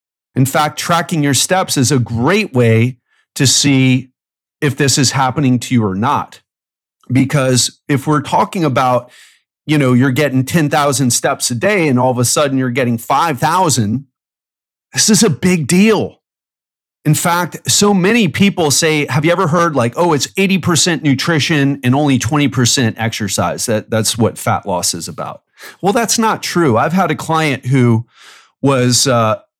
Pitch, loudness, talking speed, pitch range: 140 Hz, -13 LUFS, 165 wpm, 125-165 Hz